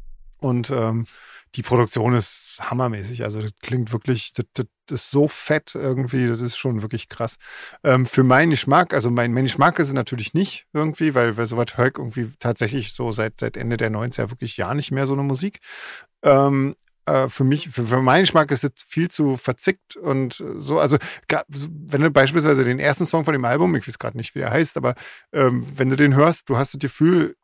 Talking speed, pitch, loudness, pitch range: 205 wpm, 130 Hz, -21 LUFS, 120-145 Hz